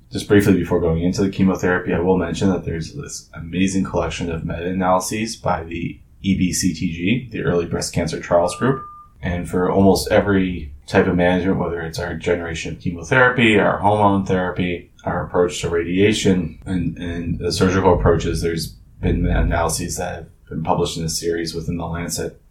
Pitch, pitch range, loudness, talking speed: 90 Hz, 85-95 Hz, -19 LUFS, 170 wpm